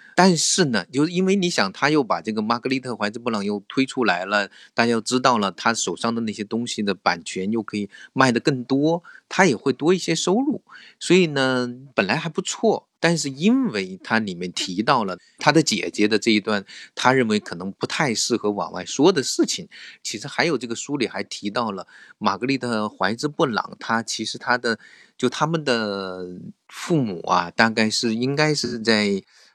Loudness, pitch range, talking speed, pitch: -22 LUFS, 110-160 Hz, 280 characters per minute, 125 Hz